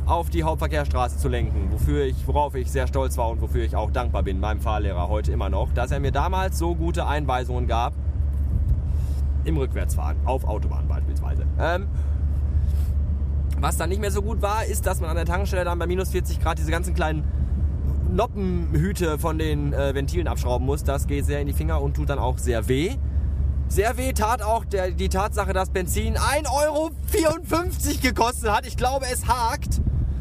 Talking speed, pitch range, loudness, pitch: 185 wpm, 70-75 Hz, -24 LUFS, 75 Hz